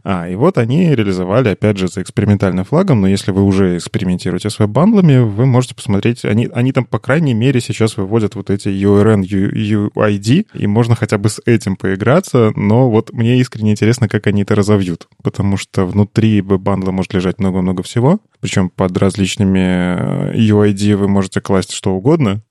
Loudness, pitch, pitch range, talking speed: -14 LUFS, 105 Hz, 95-120 Hz, 175 wpm